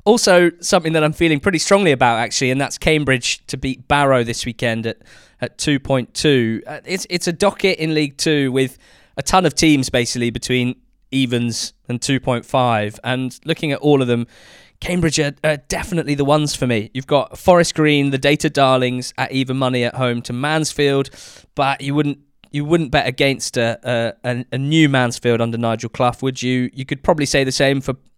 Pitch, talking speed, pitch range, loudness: 135 Hz, 190 wpm, 125-150 Hz, -17 LUFS